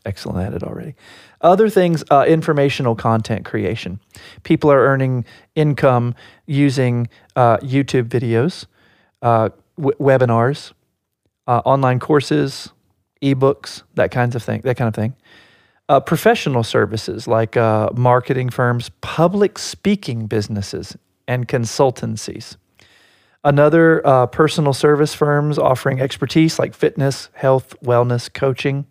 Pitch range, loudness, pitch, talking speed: 115-145 Hz, -17 LUFS, 130 Hz, 120 wpm